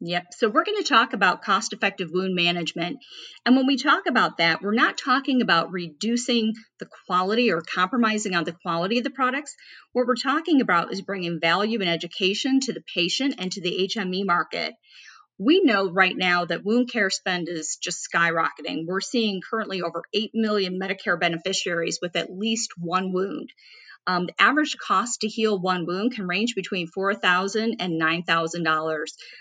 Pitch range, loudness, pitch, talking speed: 175-230 Hz, -23 LUFS, 195 Hz, 175 wpm